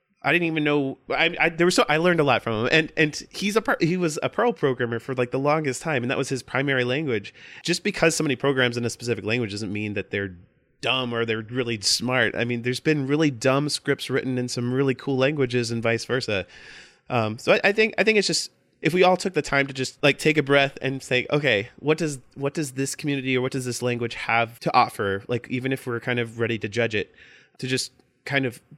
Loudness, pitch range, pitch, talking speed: -23 LUFS, 120-150 Hz, 130 Hz, 250 wpm